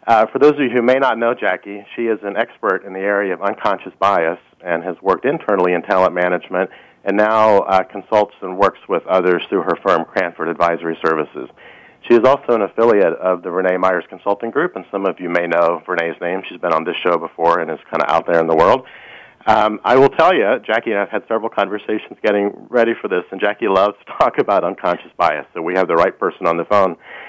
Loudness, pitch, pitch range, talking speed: -17 LUFS, 100 Hz, 90-115 Hz, 235 wpm